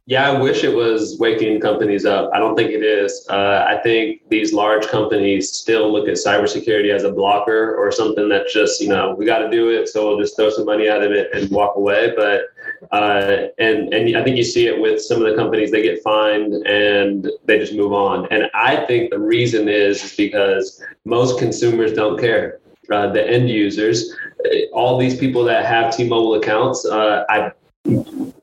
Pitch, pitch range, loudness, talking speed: 115 Hz, 105-175 Hz, -16 LUFS, 205 wpm